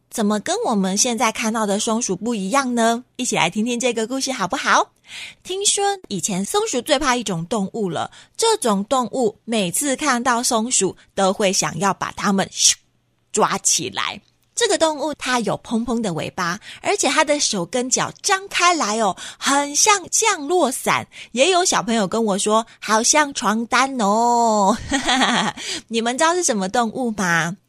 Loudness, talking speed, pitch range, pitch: -19 LUFS, 240 characters per minute, 205-275 Hz, 230 Hz